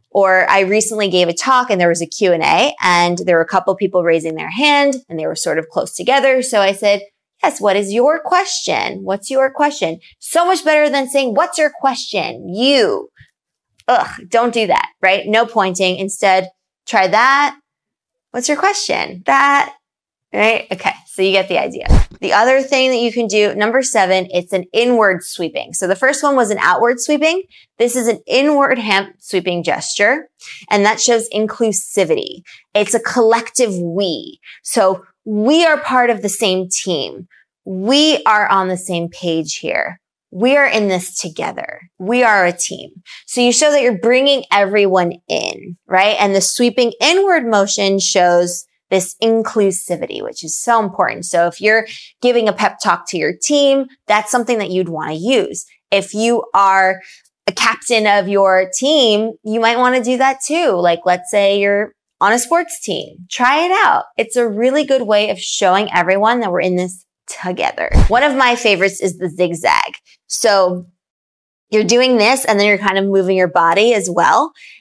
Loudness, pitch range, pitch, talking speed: -14 LUFS, 185-250 Hz, 210 Hz, 185 wpm